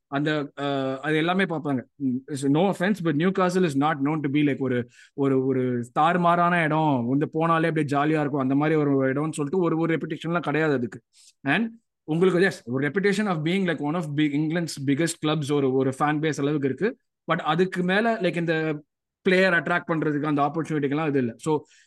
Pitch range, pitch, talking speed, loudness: 140-170 Hz, 155 Hz, 170 wpm, -24 LUFS